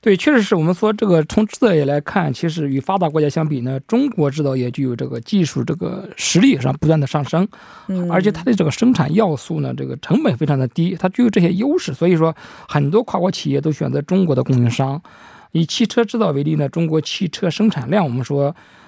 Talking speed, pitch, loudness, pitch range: 345 characters per minute, 165 Hz, -18 LUFS, 140-200 Hz